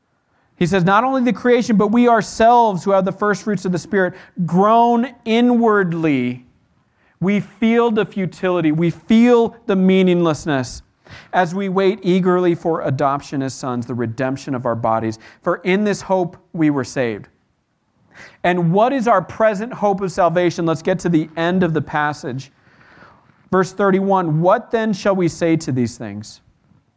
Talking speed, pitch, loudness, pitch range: 160 wpm, 180 Hz, -17 LUFS, 155-205 Hz